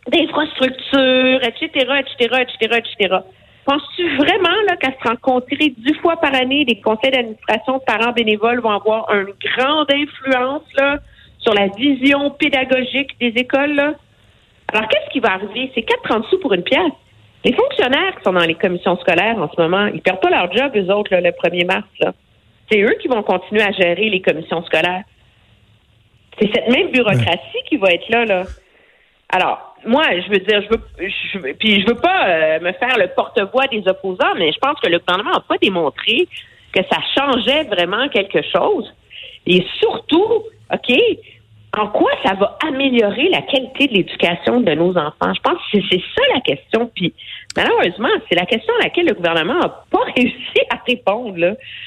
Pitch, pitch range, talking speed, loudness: 240 Hz, 195-285 Hz, 185 wpm, -16 LUFS